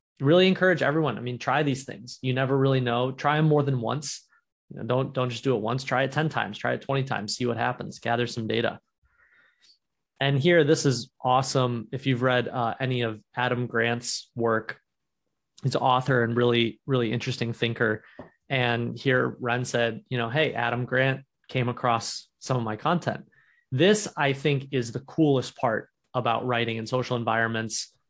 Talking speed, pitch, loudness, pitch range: 185 wpm, 125 Hz, -26 LUFS, 120-135 Hz